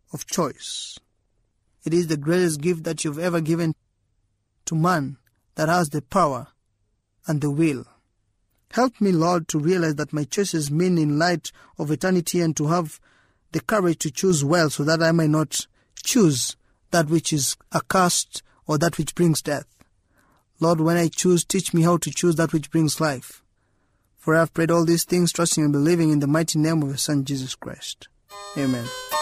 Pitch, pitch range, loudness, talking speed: 155 Hz, 135-170 Hz, -22 LUFS, 185 wpm